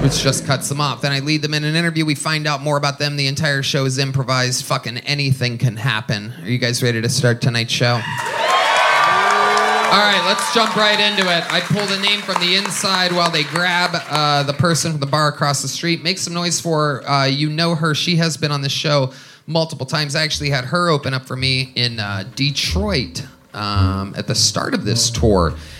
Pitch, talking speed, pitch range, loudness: 145 Hz, 225 wpm, 130-165 Hz, -17 LUFS